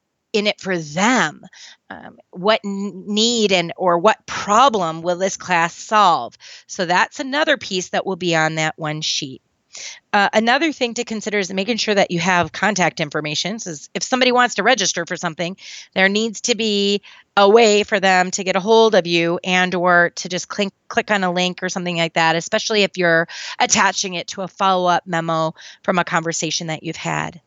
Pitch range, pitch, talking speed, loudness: 170-210 Hz, 190 Hz, 195 wpm, -18 LUFS